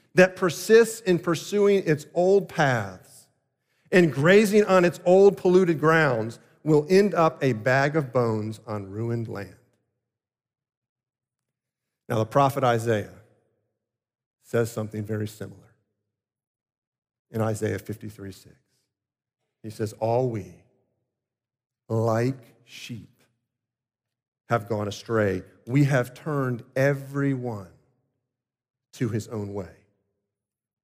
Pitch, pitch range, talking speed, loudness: 125 Hz, 110-140 Hz, 105 wpm, -23 LUFS